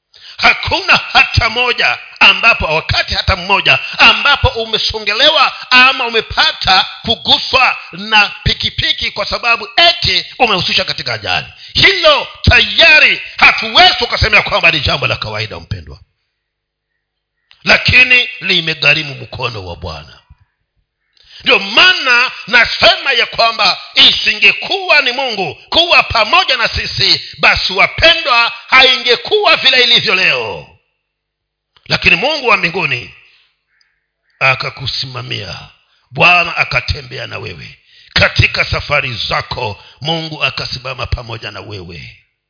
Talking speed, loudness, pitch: 100 wpm, -9 LUFS, 185 Hz